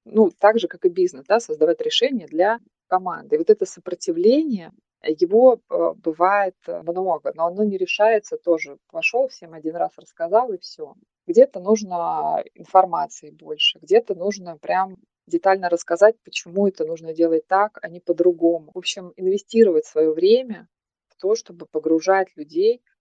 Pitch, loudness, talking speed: 205 Hz, -20 LUFS, 150 wpm